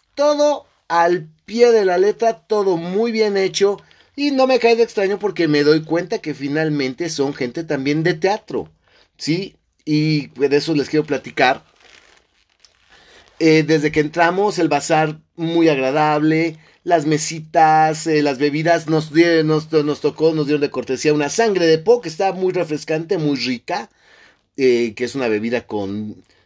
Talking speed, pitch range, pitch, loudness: 165 wpm, 145-180 Hz, 155 Hz, -18 LUFS